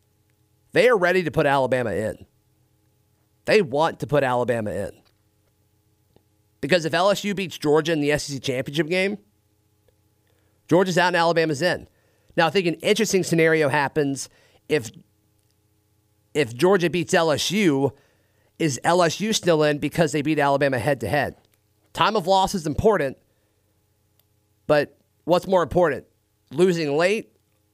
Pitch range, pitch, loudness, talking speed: 105-170 Hz, 140 Hz, -21 LUFS, 135 wpm